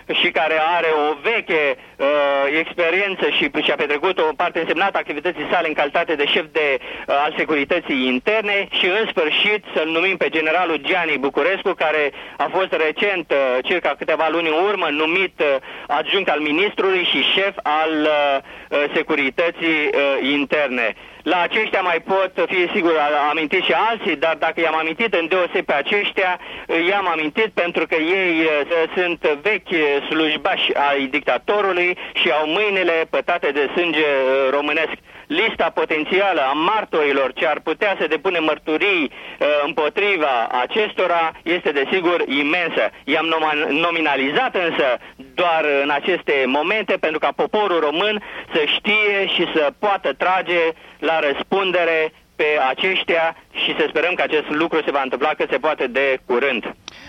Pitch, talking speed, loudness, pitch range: 165 Hz, 150 wpm, -18 LUFS, 150-195 Hz